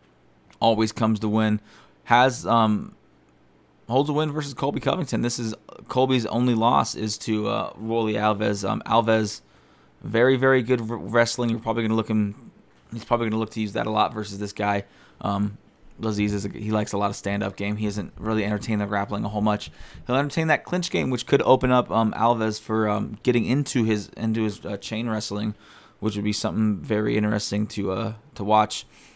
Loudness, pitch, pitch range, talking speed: -24 LUFS, 110 Hz, 105-115 Hz, 205 wpm